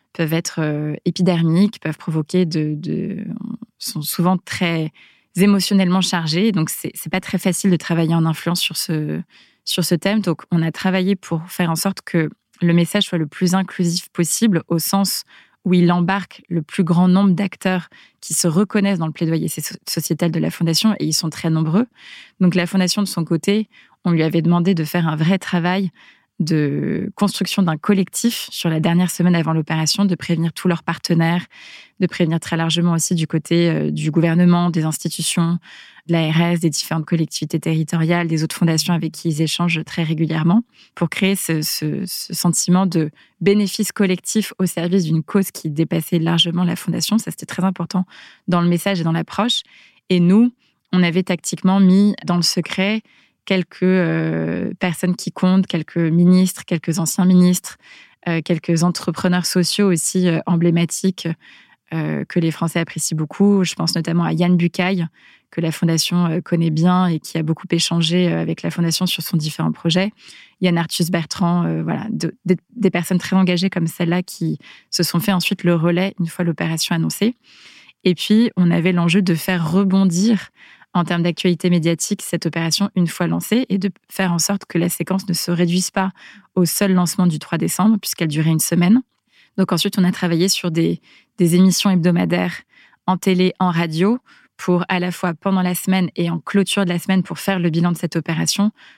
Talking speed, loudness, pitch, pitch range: 185 wpm, -18 LUFS, 175 Hz, 165-190 Hz